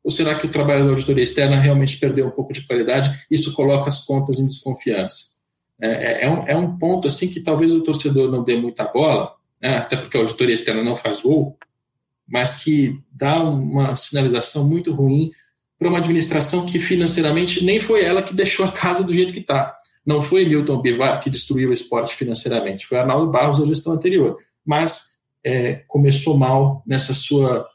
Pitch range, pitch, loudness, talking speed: 135-165 Hz, 140 Hz, -18 LUFS, 190 wpm